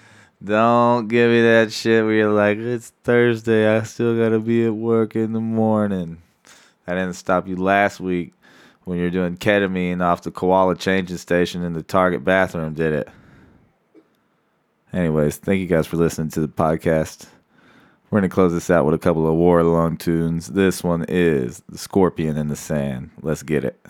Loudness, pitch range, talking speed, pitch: -19 LUFS, 85-110 Hz, 185 wpm, 90 Hz